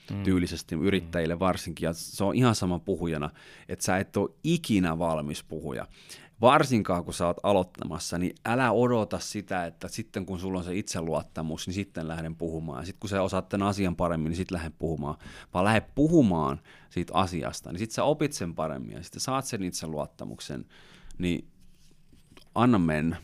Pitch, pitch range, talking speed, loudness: 90 Hz, 80-100 Hz, 175 wpm, -28 LUFS